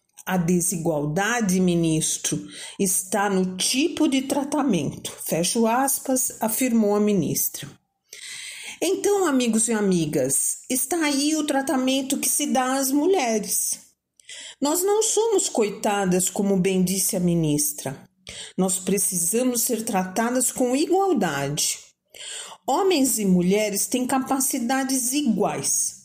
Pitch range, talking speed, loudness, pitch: 185-275 Hz, 110 wpm, -22 LUFS, 230 Hz